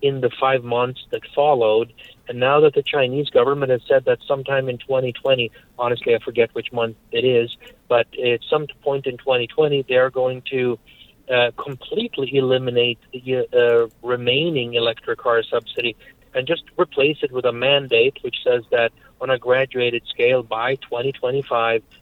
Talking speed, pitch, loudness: 165 wpm, 135 Hz, -20 LUFS